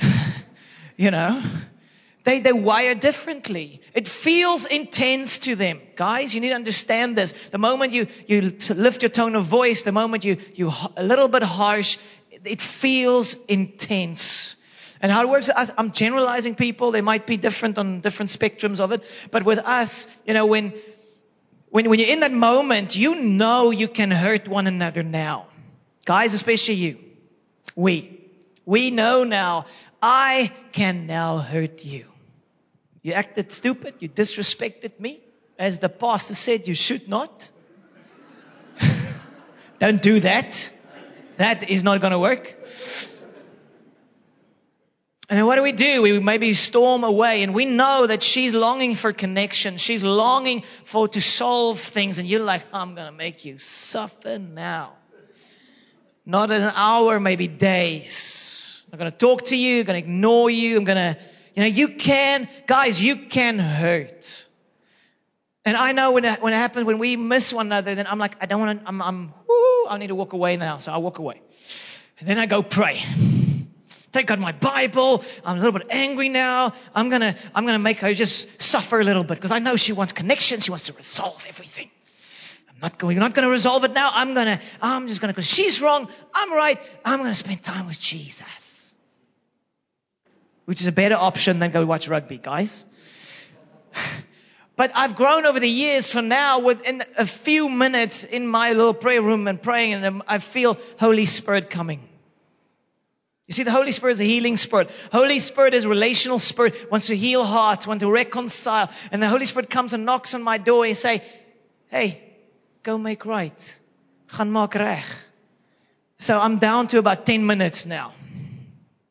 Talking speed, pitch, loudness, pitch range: 175 wpm, 220 Hz, -20 LUFS, 195-245 Hz